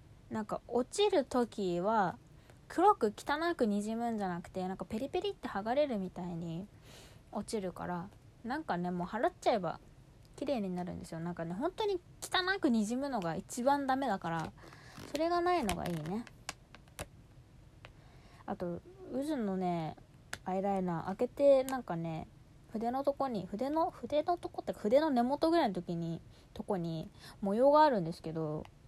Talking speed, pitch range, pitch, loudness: 310 characters per minute, 170-275 Hz, 205 Hz, -34 LUFS